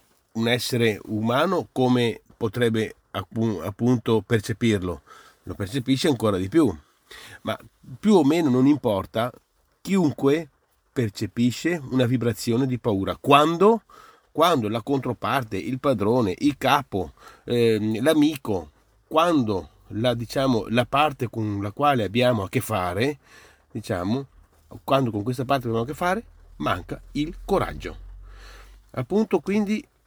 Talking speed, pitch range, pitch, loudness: 120 wpm, 105-140 Hz, 120 Hz, -23 LUFS